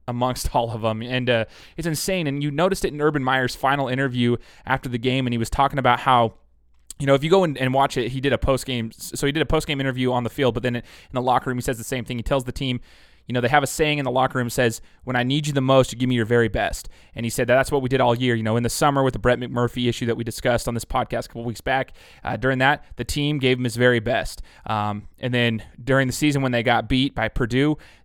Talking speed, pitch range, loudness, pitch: 295 wpm, 120-135 Hz, -22 LUFS, 125 Hz